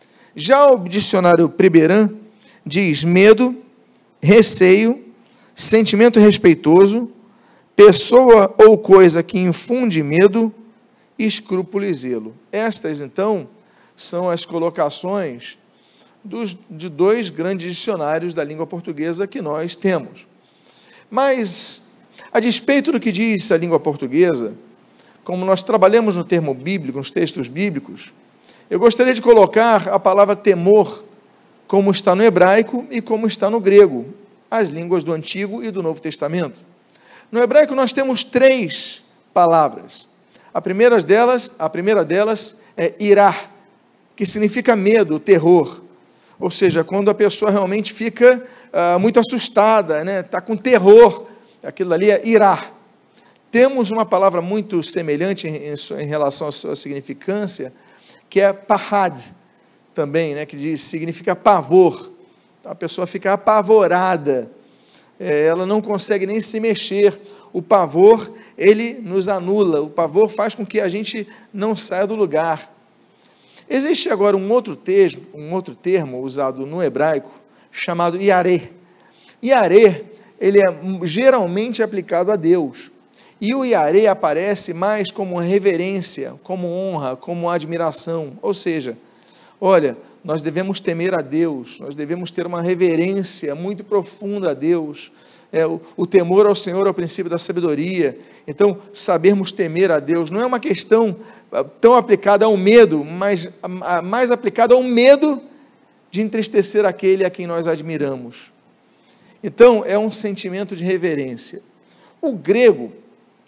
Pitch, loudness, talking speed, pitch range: 195 Hz, -16 LUFS, 135 wpm, 175-220 Hz